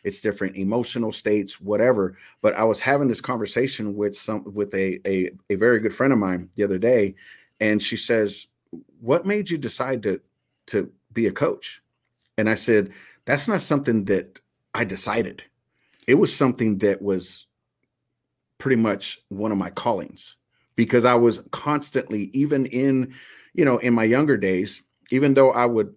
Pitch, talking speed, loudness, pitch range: 110 Hz, 170 wpm, -22 LUFS, 100-130 Hz